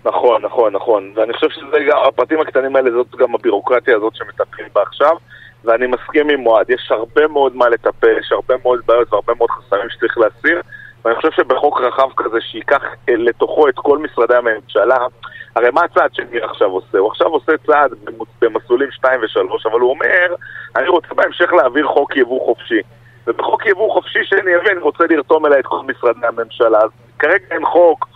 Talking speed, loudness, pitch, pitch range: 180 wpm, -14 LUFS, 150 Hz, 120-195 Hz